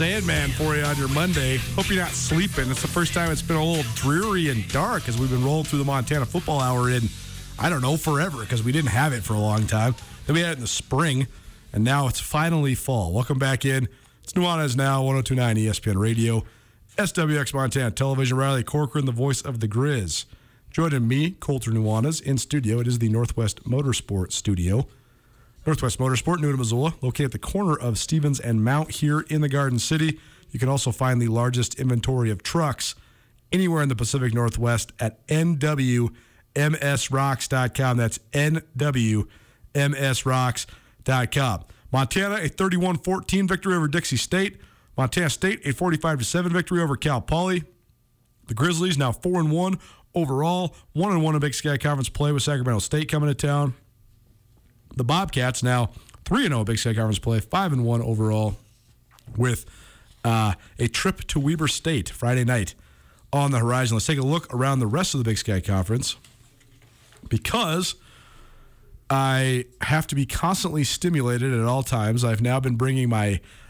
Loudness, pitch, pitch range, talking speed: -23 LUFS, 130 Hz, 115-150 Hz, 170 wpm